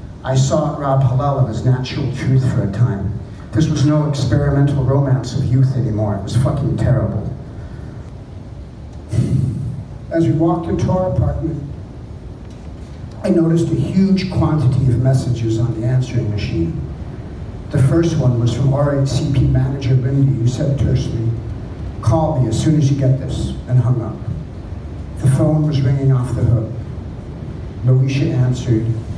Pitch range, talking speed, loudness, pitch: 115-140 Hz, 145 wpm, -17 LUFS, 130 Hz